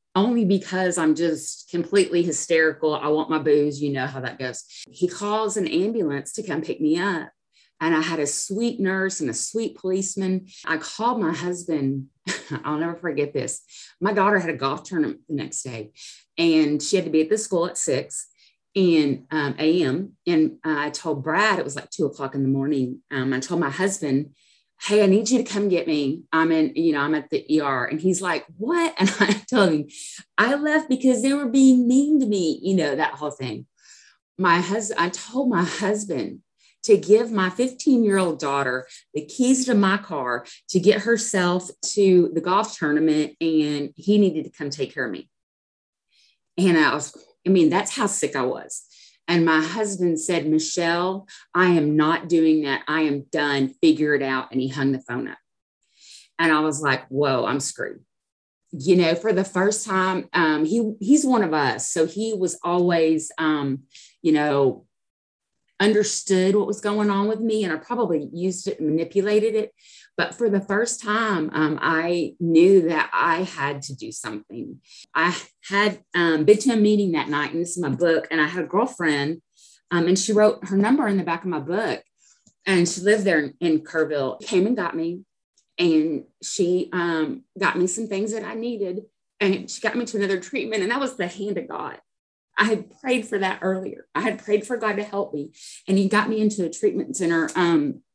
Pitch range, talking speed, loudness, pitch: 155-210 Hz, 200 wpm, -22 LUFS, 180 Hz